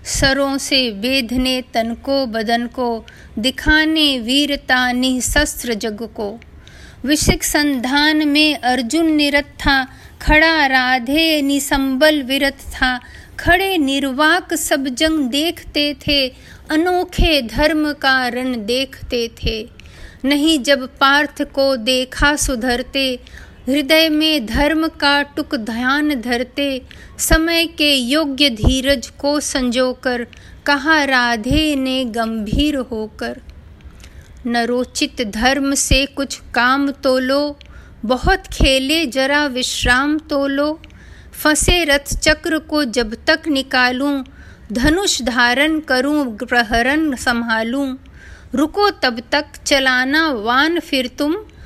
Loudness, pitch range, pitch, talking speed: -16 LUFS, 250-300 Hz, 275 Hz, 105 wpm